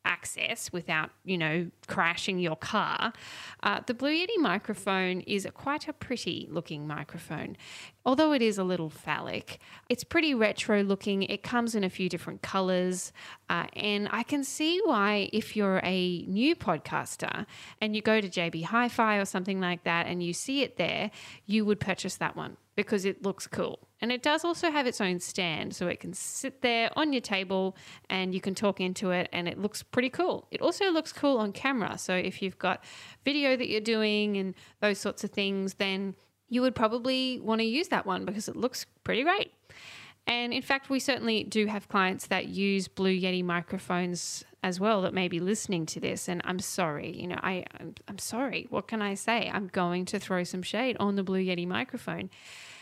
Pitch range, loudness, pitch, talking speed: 180-230 Hz, -30 LUFS, 195 Hz, 200 wpm